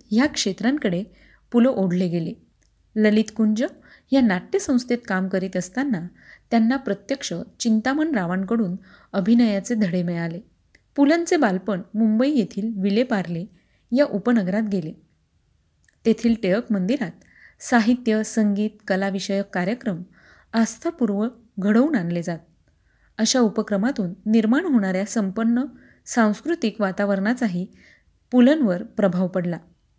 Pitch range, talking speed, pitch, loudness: 195-240 Hz, 100 wpm, 215 Hz, -22 LUFS